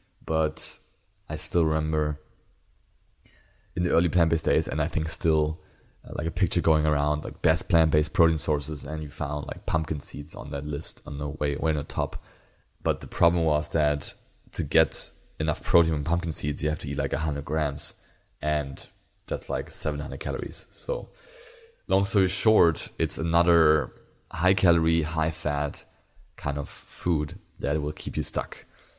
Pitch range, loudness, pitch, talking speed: 75-85 Hz, -26 LUFS, 80 Hz, 175 wpm